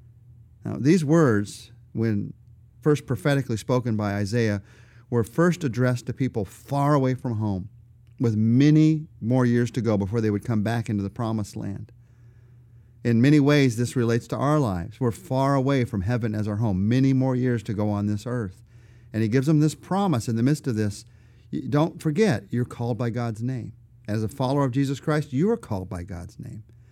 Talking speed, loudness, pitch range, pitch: 195 wpm, -24 LUFS, 110-135 Hz, 120 Hz